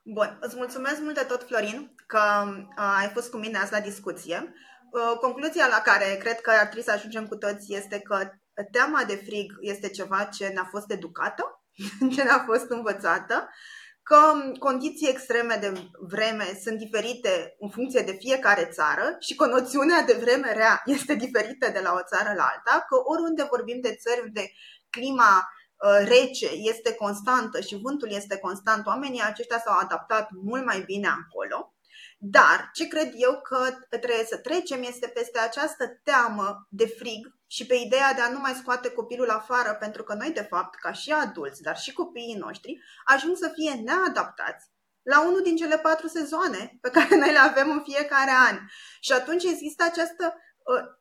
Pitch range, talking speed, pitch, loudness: 210-280 Hz, 175 wpm, 245 Hz, -24 LUFS